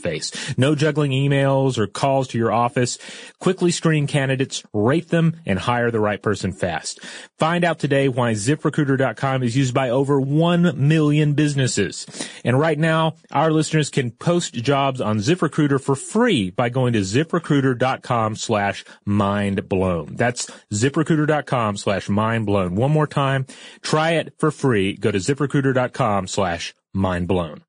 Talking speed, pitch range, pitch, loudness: 145 wpm, 110-155 Hz, 135 Hz, -20 LUFS